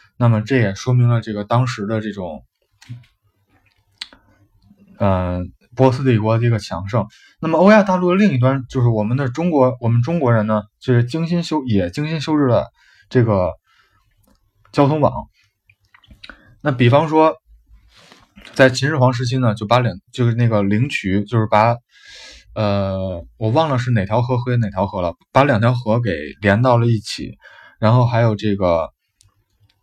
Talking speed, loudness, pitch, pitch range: 235 characters per minute, -17 LUFS, 115 Hz, 100-130 Hz